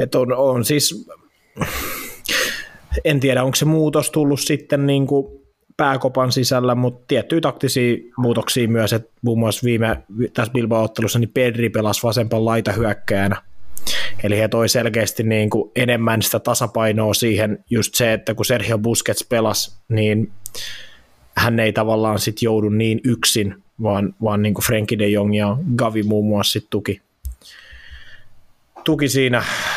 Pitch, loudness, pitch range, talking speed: 115 Hz, -18 LUFS, 110-125 Hz, 135 wpm